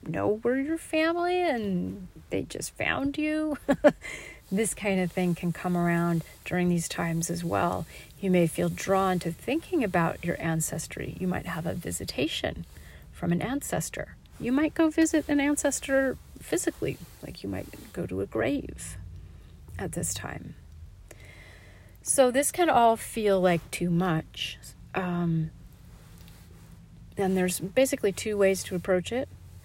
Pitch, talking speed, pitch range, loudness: 180 Hz, 145 wpm, 160-270 Hz, -28 LUFS